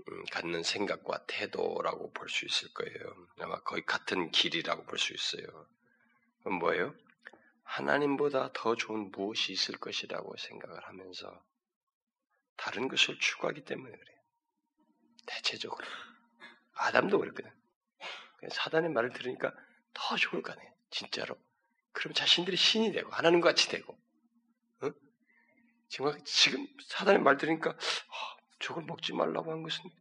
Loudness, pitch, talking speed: -32 LUFS, 230 Hz, 285 characters per minute